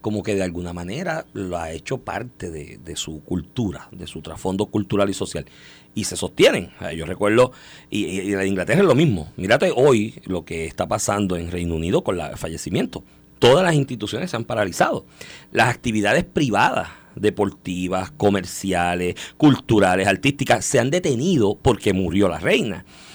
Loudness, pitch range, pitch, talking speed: -21 LUFS, 90-105 Hz, 100 Hz, 165 wpm